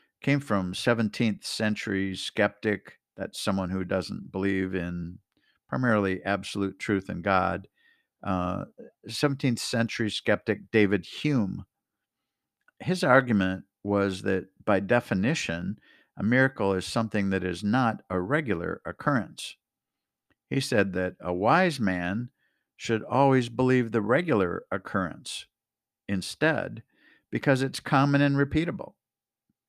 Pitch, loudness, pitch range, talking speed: 105 Hz, -27 LUFS, 95-130 Hz, 115 wpm